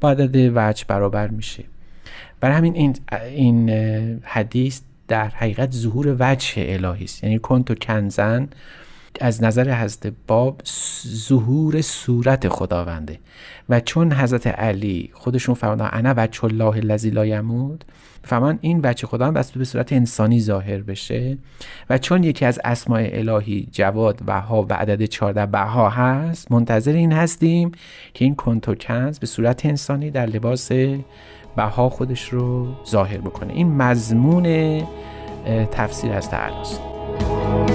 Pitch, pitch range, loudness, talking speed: 120 Hz, 105-130 Hz, -20 LUFS, 130 wpm